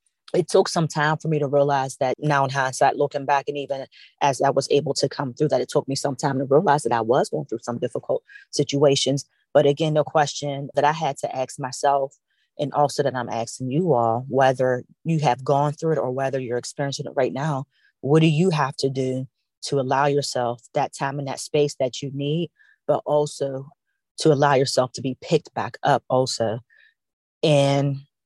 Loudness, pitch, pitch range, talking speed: -22 LUFS, 140 Hz, 130-145 Hz, 210 wpm